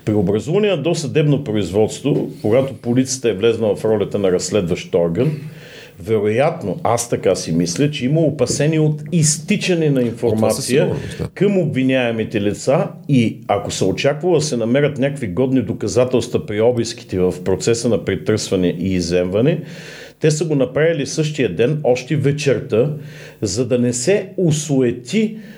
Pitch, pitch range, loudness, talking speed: 130 Hz, 115-155 Hz, -18 LUFS, 140 wpm